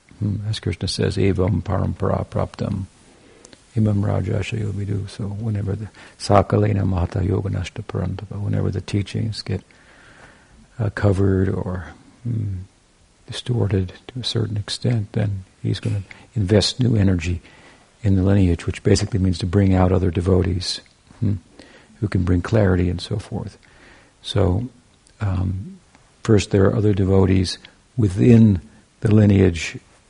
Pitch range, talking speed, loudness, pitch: 95-110 Hz, 130 wpm, -21 LUFS, 100 Hz